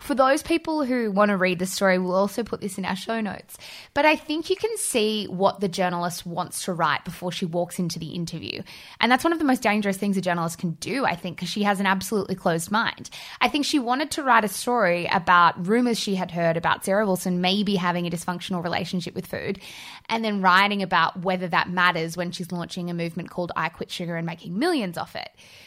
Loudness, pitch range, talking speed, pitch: -24 LUFS, 175-225 Hz, 235 wpm, 190 Hz